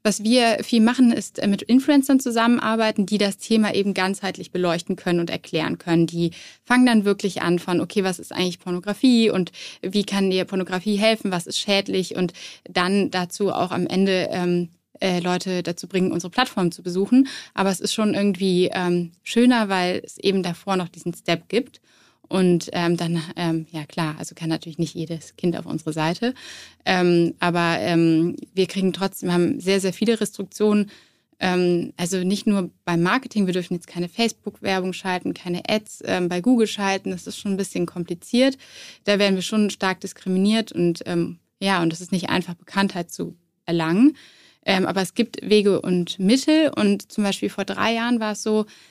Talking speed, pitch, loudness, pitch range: 185 wpm, 190 Hz, -22 LUFS, 175-210 Hz